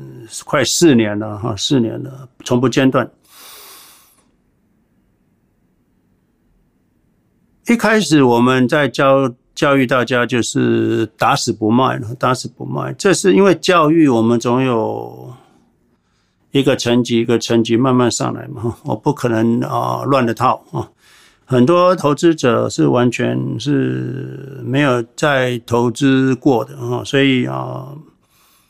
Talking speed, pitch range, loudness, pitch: 180 characters per minute, 115-135 Hz, -15 LUFS, 125 Hz